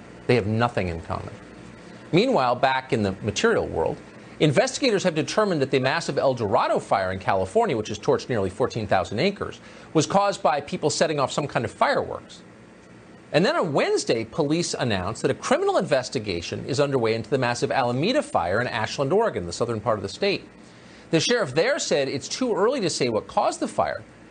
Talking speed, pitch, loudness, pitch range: 190 wpm, 135 Hz, -24 LUFS, 105-155 Hz